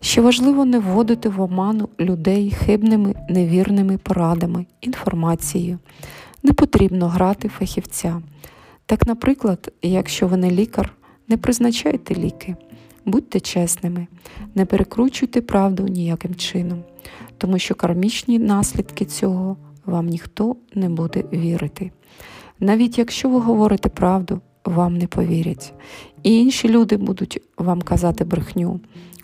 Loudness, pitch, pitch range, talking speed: -19 LUFS, 190 Hz, 175-215 Hz, 115 wpm